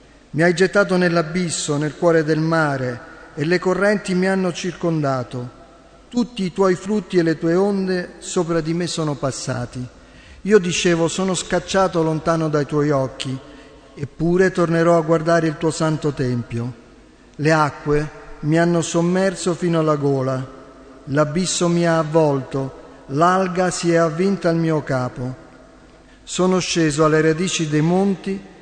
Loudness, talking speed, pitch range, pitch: -19 LUFS, 145 wpm, 145-180 Hz, 165 Hz